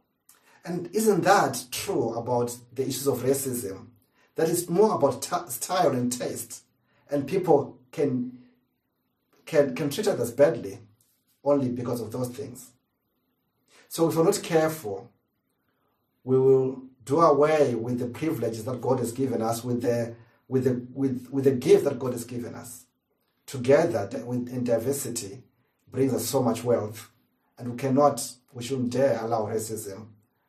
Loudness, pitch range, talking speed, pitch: -26 LUFS, 120-140 Hz, 150 wpm, 125 Hz